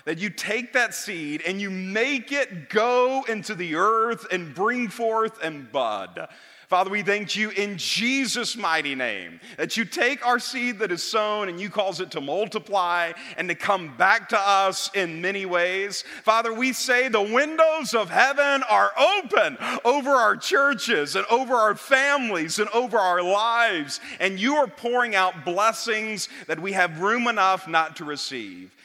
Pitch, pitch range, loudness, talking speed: 215 Hz, 185-240 Hz, -23 LUFS, 175 wpm